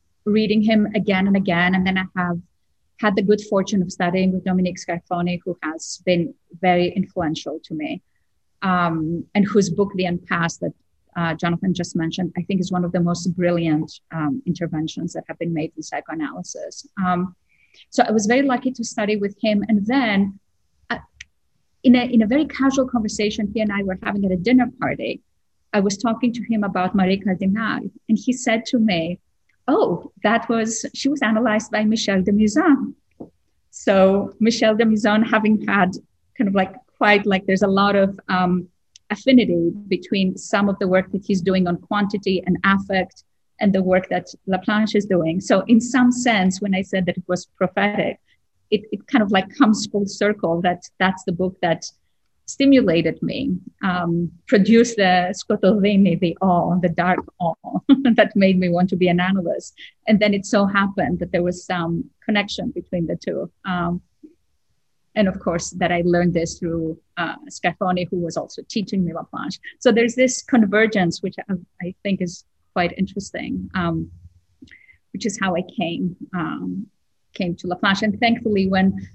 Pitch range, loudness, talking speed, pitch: 180-215 Hz, -20 LUFS, 180 wpm, 195 Hz